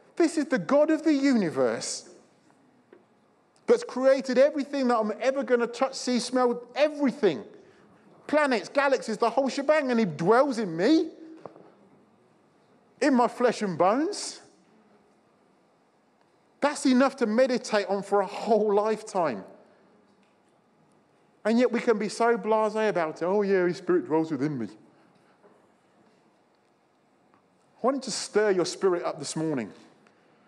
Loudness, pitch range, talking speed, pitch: -26 LUFS, 210-275 Hz, 135 wpm, 240 Hz